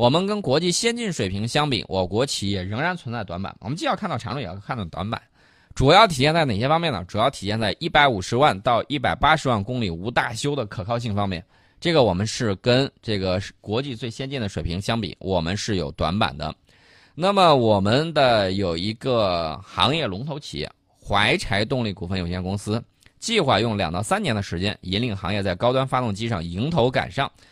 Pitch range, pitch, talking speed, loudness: 95-135 Hz, 110 Hz, 320 characters per minute, -22 LUFS